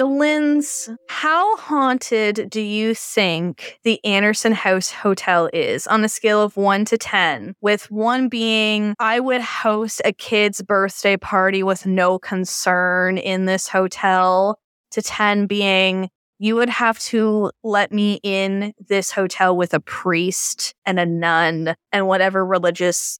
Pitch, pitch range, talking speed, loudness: 205 Hz, 190-220 Hz, 140 wpm, -18 LUFS